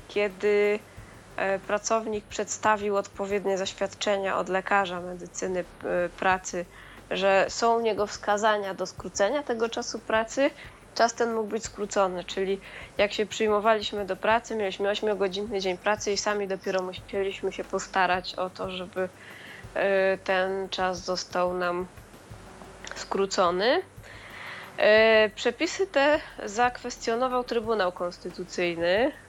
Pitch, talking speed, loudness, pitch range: 200 Hz, 110 wpm, -27 LUFS, 185-220 Hz